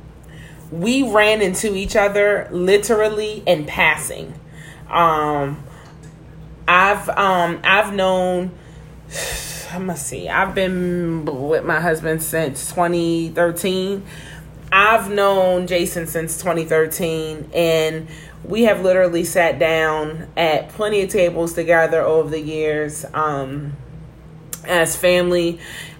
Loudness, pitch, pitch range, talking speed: -18 LUFS, 165 Hz, 155-185 Hz, 110 wpm